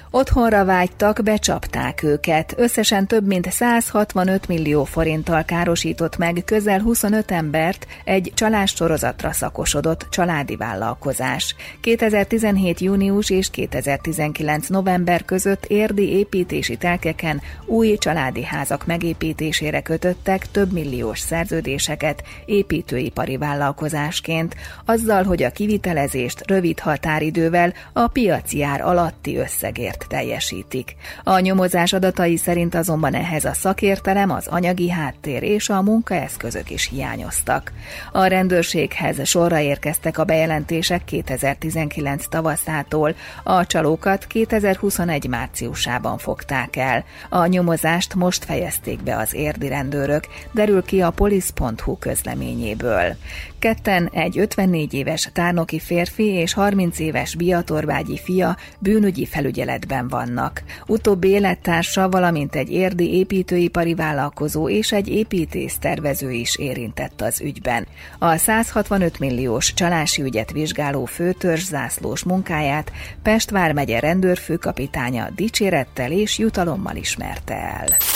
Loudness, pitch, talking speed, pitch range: -20 LUFS, 170 Hz, 105 wpm, 150-195 Hz